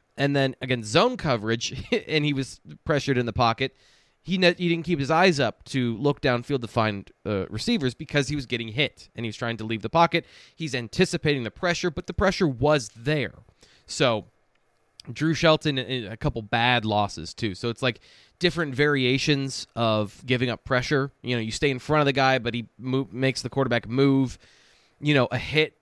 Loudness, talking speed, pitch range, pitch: -25 LUFS, 200 wpm, 120-150 Hz, 130 Hz